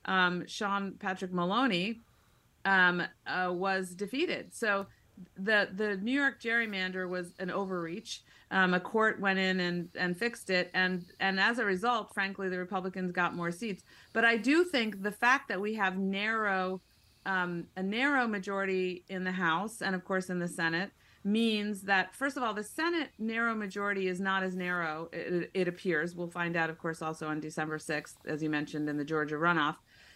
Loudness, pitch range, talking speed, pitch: -32 LUFS, 175-210 Hz, 185 wpm, 190 Hz